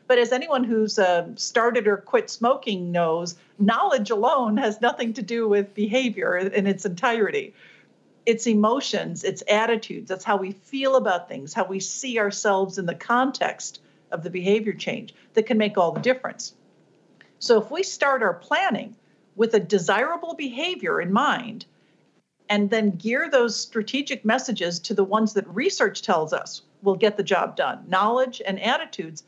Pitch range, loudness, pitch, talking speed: 195-250 Hz, -23 LUFS, 220 Hz, 165 wpm